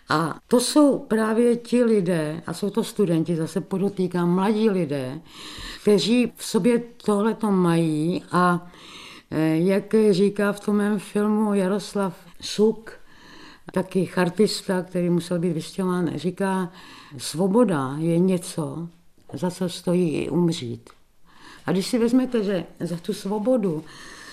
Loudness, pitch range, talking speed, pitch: -23 LUFS, 170-210 Hz, 125 wpm, 190 Hz